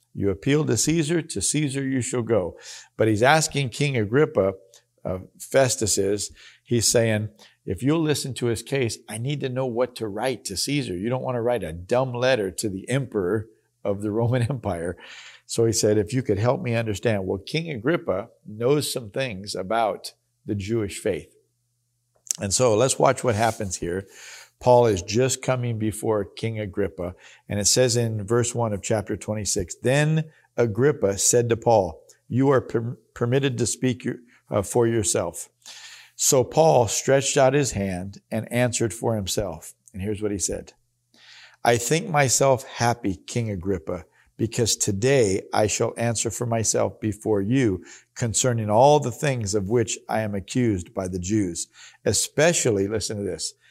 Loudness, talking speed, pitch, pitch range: -23 LUFS, 170 wpm, 120 Hz, 105-130 Hz